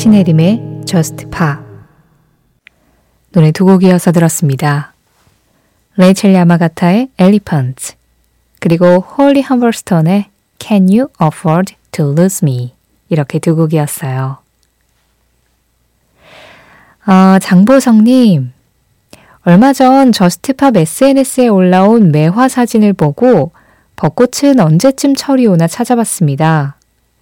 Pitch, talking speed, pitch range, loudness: 175 Hz, 260 characters per minute, 150-220 Hz, -10 LUFS